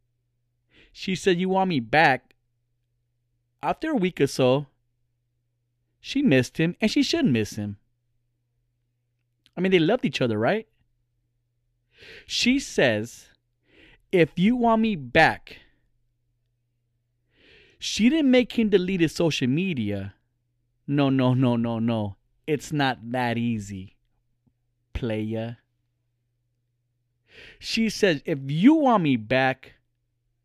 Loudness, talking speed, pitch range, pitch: -23 LUFS, 115 wpm, 120-155 Hz, 120 Hz